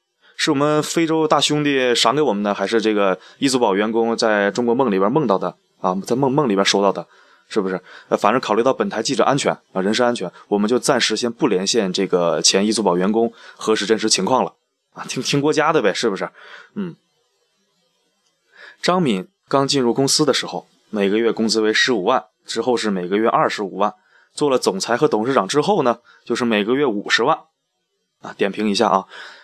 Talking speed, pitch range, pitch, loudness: 300 characters per minute, 110-150 Hz, 120 Hz, -18 LUFS